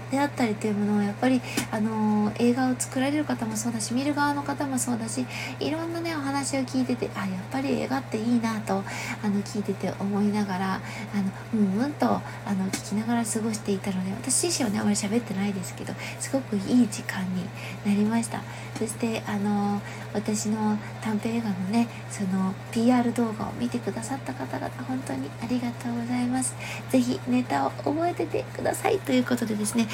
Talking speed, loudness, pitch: 385 characters per minute, -27 LUFS, 200 Hz